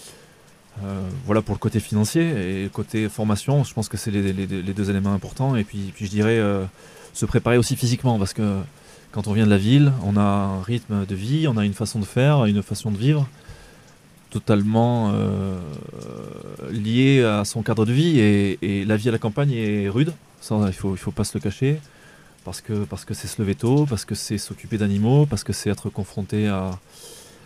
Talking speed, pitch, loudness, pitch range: 220 wpm, 110 Hz, -22 LUFS, 100-120 Hz